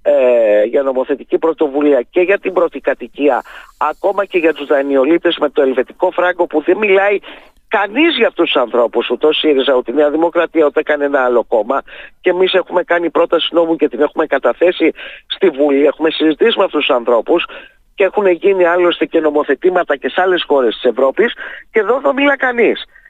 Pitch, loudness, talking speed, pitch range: 165 Hz, -14 LUFS, 180 wpm, 145-185 Hz